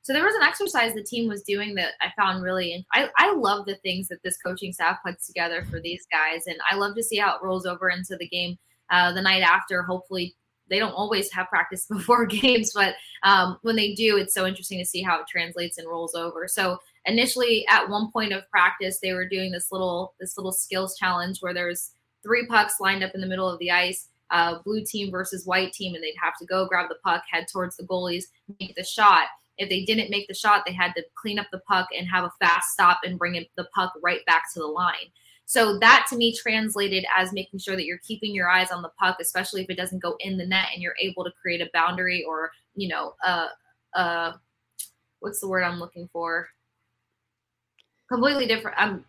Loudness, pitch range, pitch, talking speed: -24 LUFS, 175-200 Hz, 185 Hz, 230 wpm